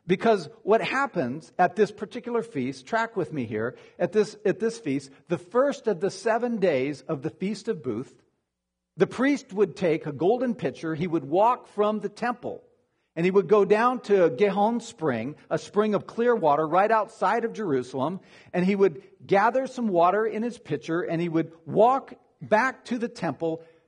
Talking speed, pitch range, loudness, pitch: 185 wpm, 165-225 Hz, -25 LUFS, 195 Hz